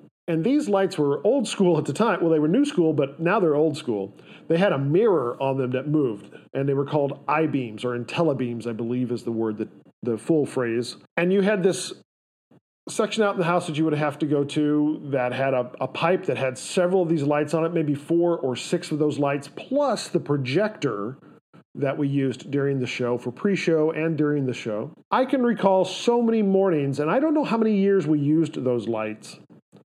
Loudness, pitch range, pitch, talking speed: -23 LUFS, 130-180 Hz, 150 Hz, 225 wpm